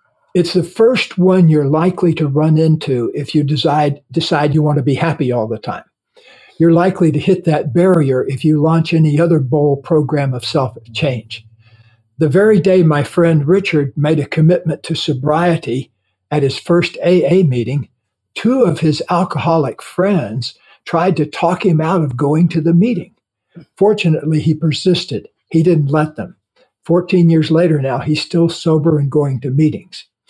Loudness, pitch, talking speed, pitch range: -14 LUFS, 155 Hz, 170 wpm, 145-170 Hz